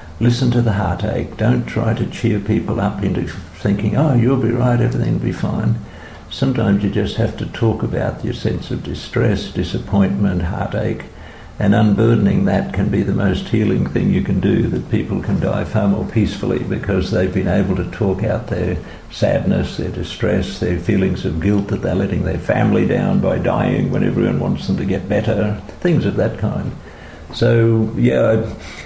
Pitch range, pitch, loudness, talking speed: 95-110 Hz, 100 Hz, -18 LUFS, 185 wpm